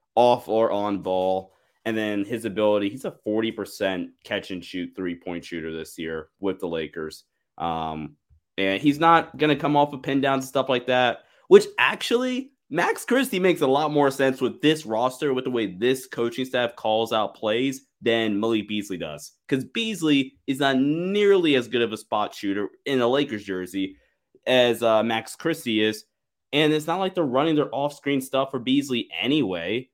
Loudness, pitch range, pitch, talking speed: -24 LUFS, 105-145 Hz, 125 Hz, 190 wpm